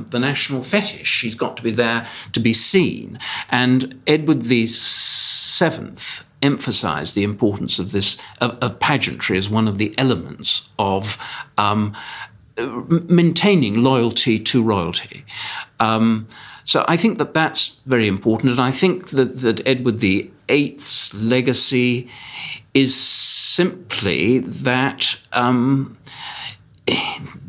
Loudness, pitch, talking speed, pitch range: -17 LUFS, 125 Hz, 115 wpm, 110-135 Hz